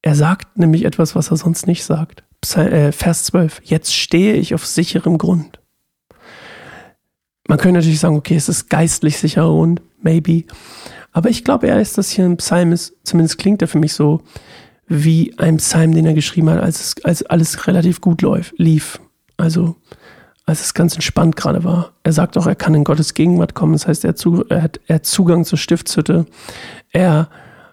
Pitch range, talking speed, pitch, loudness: 160-175 Hz, 175 wpm, 165 Hz, -15 LUFS